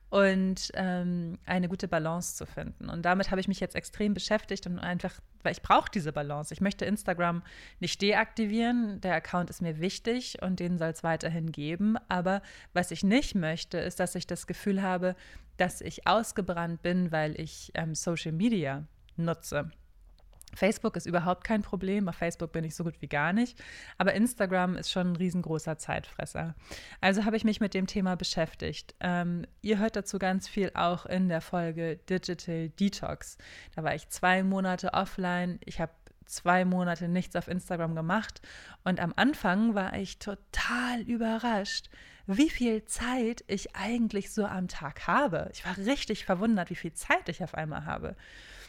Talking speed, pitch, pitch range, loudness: 175 wpm, 185 Hz, 170-200 Hz, -31 LUFS